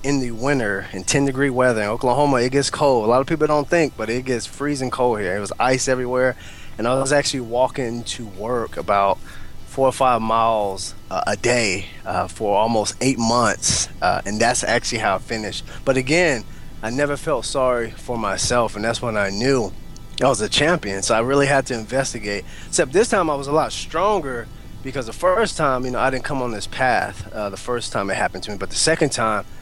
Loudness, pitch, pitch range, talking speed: -20 LUFS, 120 Hz, 110-135 Hz, 225 wpm